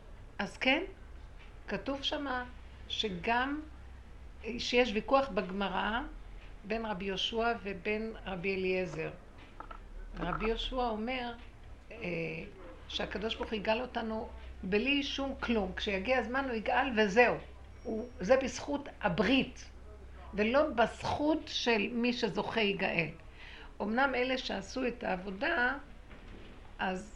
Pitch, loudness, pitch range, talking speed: 230 Hz, -33 LUFS, 205-255 Hz, 105 wpm